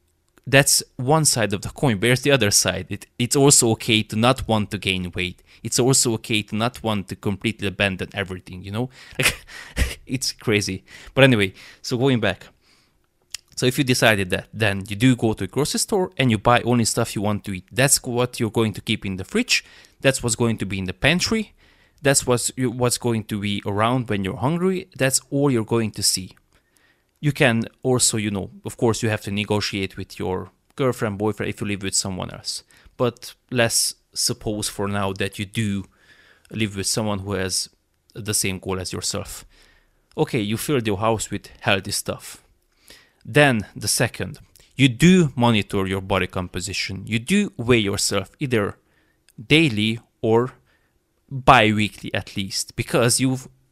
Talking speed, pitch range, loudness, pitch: 180 wpm, 100-125 Hz, -21 LUFS, 110 Hz